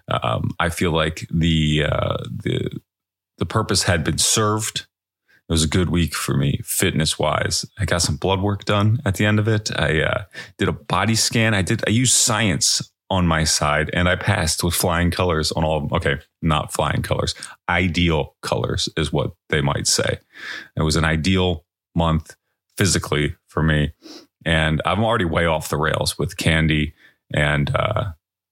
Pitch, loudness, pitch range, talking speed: 85 Hz, -20 LUFS, 80-100 Hz, 180 wpm